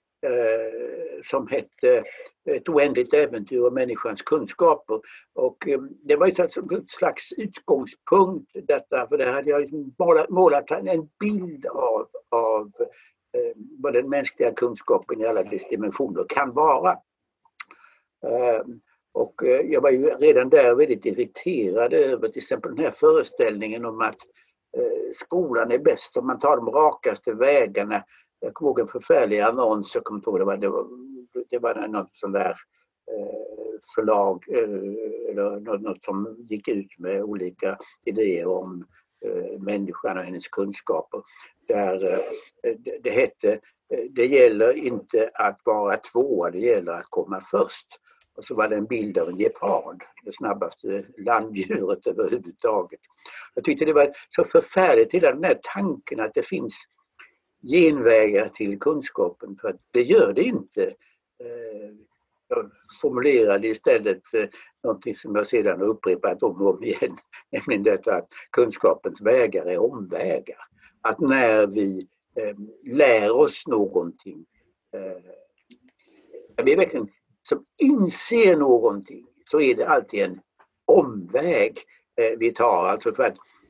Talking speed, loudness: 135 wpm, -23 LUFS